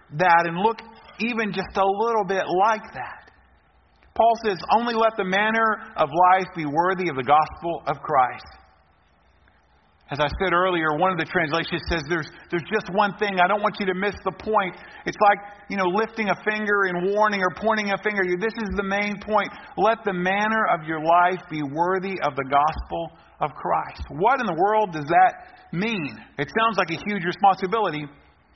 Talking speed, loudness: 195 wpm, -22 LUFS